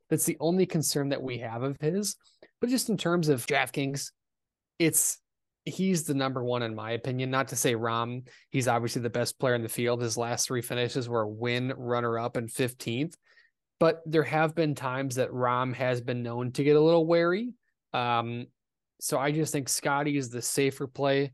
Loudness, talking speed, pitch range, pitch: -28 LUFS, 200 wpm, 120-155 Hz, 135 Hz